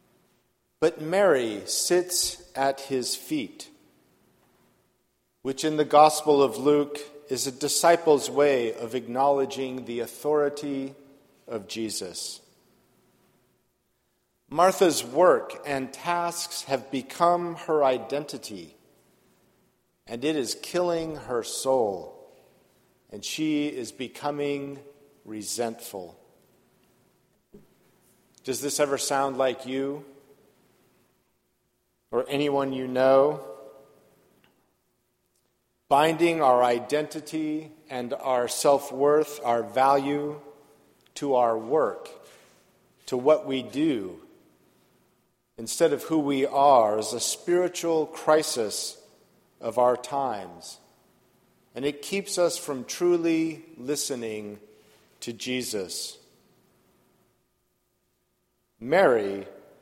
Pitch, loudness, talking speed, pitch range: 140 Hz, -25 LUFS, 90 wpm, 130-160 Hz